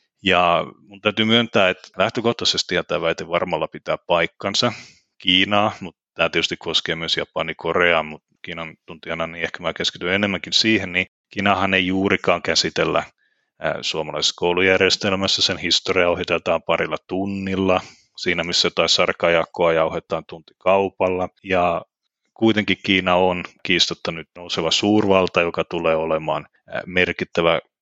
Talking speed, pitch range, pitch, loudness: 125 wpm, 90-100 Hz, 95 Hz, -20 LUFS